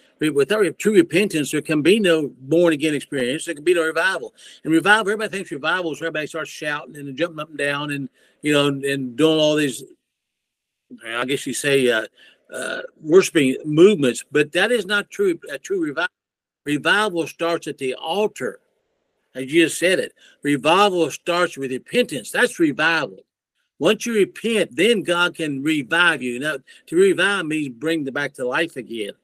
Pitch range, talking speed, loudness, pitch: 145-205 Hz, 175 wpm, -20 LUFS, 160 Hz